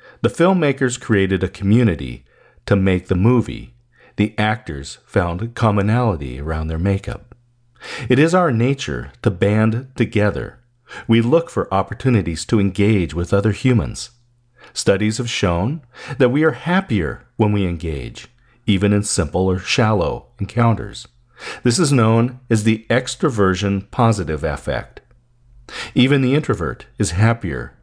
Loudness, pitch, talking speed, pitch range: -18 LUFS, 110 Hz, 130 wpm, 100-120 Hz